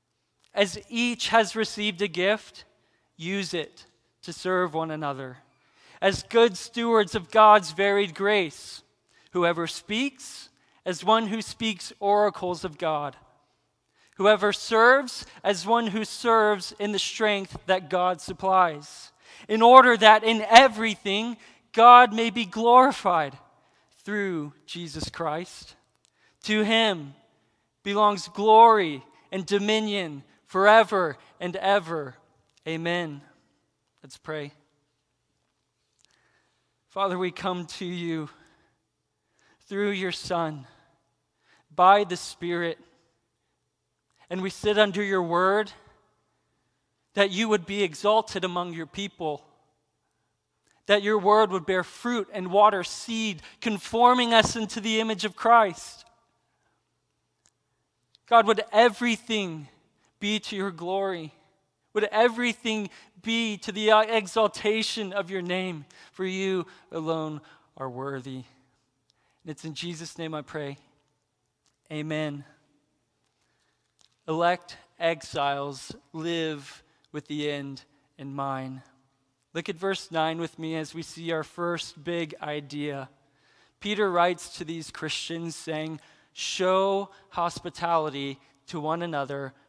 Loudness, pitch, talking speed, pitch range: -24 LUFS, 185 Hz, 110 wpm, 155-215 Hz